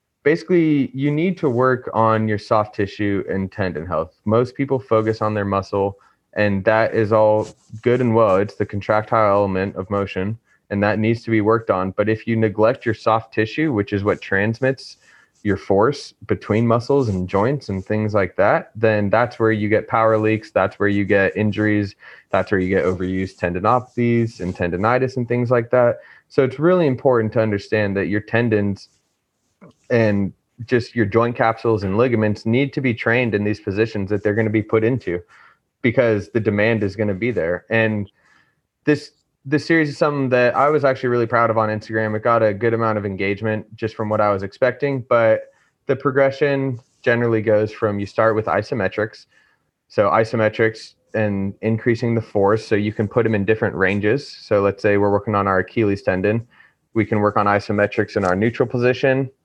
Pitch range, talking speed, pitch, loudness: 105-120 Hz, 195 wpm, 110 Hz, -19 LUFS